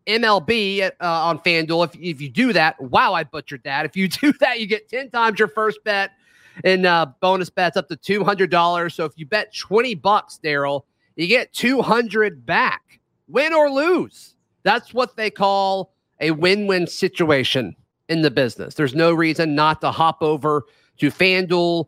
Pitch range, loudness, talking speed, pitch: 160-215 Hz, -19 LUFS, 180 wpm, 185 Hz